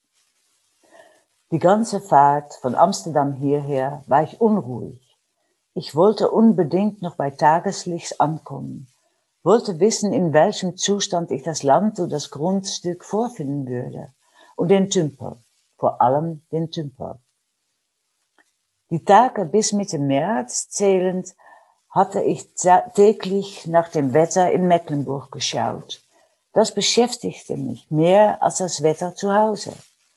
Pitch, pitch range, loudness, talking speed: 175 Hz, 145-200 Hz, -20 LUFS, 120 wpm